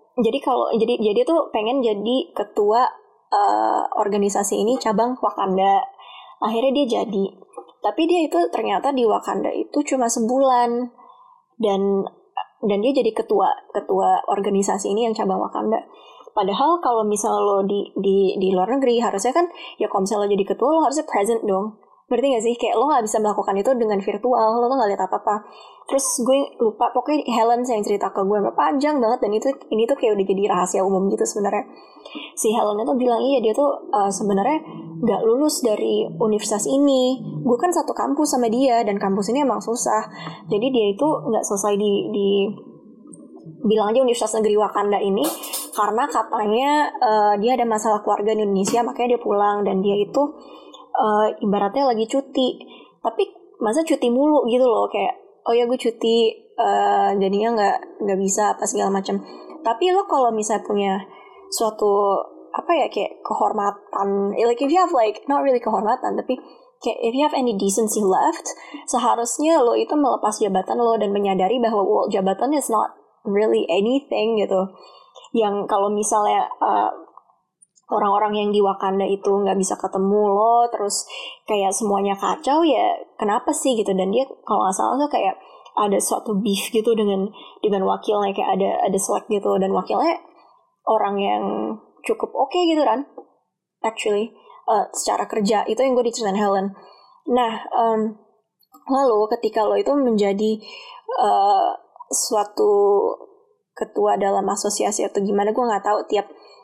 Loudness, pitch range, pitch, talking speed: -20 LUFS, 205-270 Hz, 225 Hz, 165 wpm